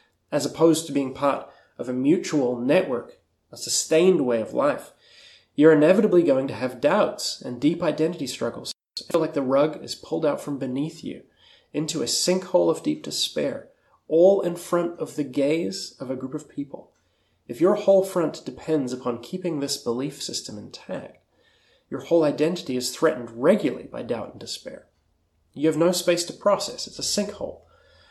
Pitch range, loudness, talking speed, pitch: 135-175 Hz, -23 LUFS, 175 wpm, 155 Hz